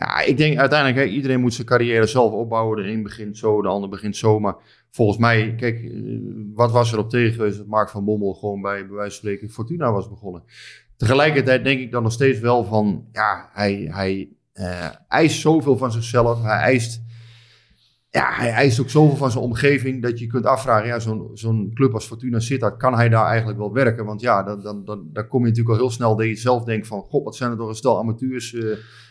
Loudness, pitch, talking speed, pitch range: -20 LUFS, 115 Hz, 225 wpm, 105-125 Hz